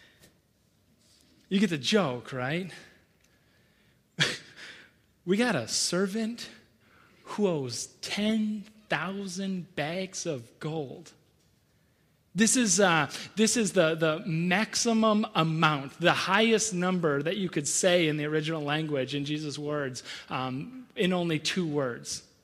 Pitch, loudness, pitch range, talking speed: 170 Hz, -28 LUFS, 150-200 Hz, 115 wpm